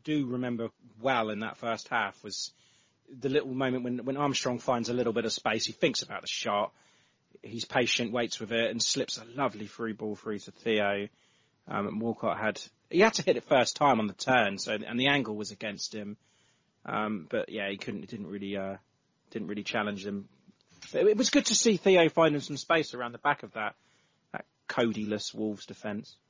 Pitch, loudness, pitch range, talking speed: 115 Hz, -30 LUFS, 105-135 Hz, 210 wpm